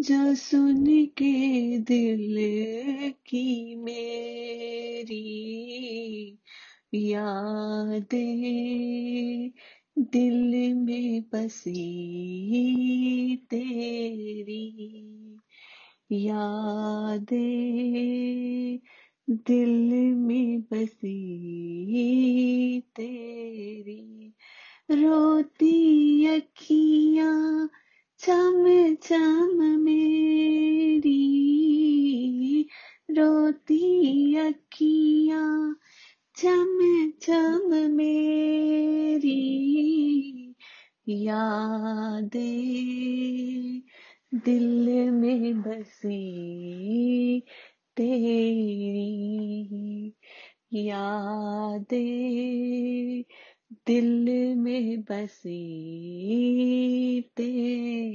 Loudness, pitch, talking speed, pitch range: -25 LUFS, 245 Hz, 35 wpm, 220-285 Hz